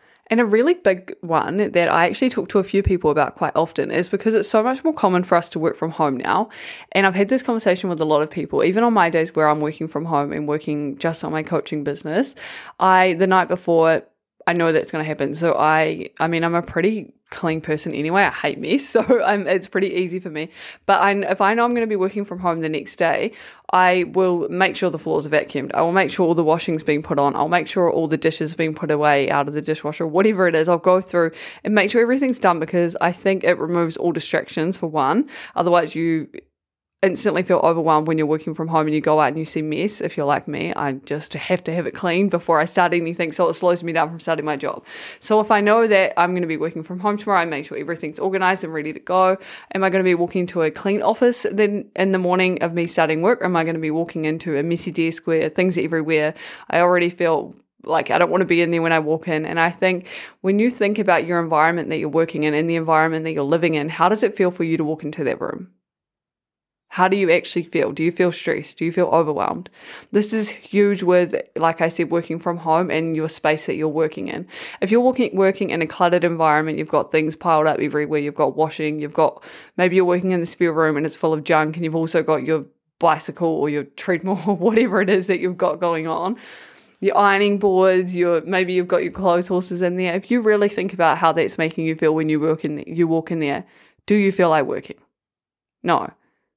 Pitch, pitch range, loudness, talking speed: 170 Hz, 160-190 Hz, -19 LUFS, 255 wpm